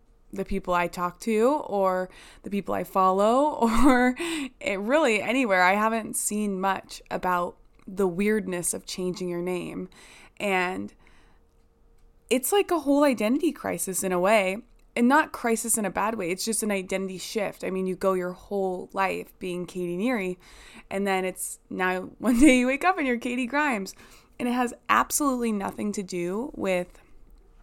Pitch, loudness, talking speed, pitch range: 200 Hz, -25 LUFS, 170 wpm, 185-250 Hz